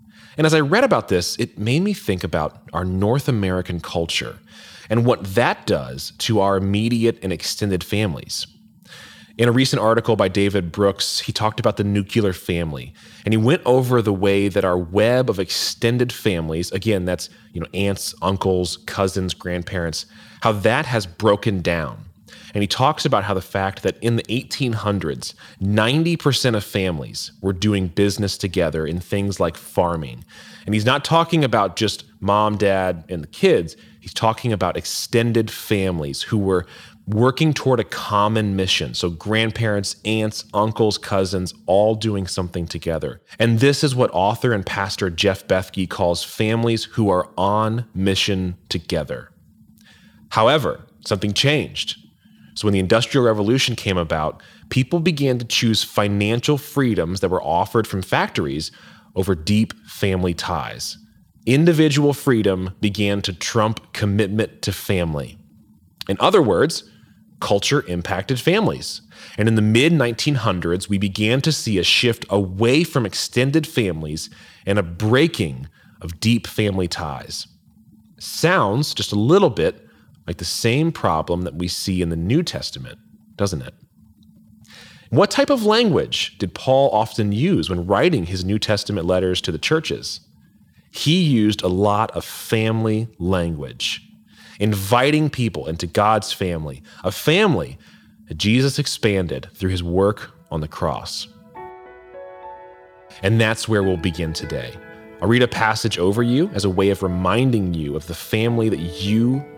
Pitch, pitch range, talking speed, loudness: 105 Hz, 95-115 Hz, 150 wpm, -20 LUFS